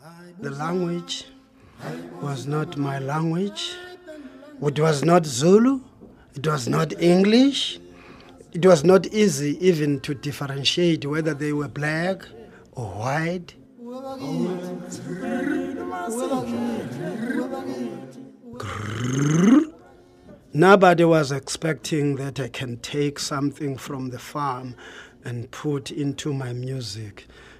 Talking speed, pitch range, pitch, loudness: 95 wpm, 140-195 Hz, 155 Hz, -23 LUFS